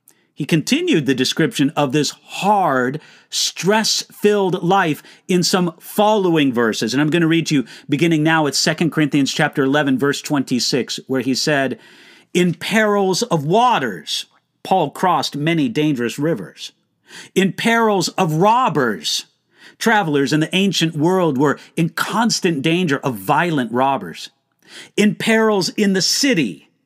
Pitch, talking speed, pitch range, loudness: 165 Hz, 140 wpm, 145-195 Hz, -17 LUFS